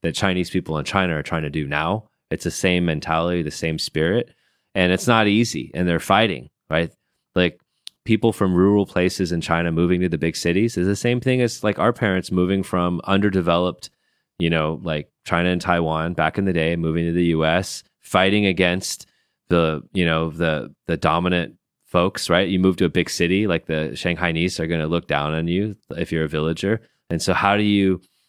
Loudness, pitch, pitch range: -21 LUFS, 90 Hz, 80-95 Hz